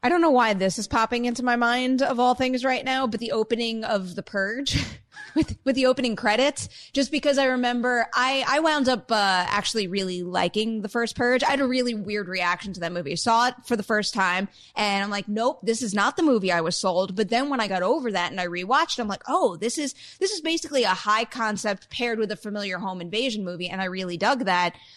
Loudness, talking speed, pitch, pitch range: -24 LUFS, 245 wpm, 225 Hz, 195-255 Hz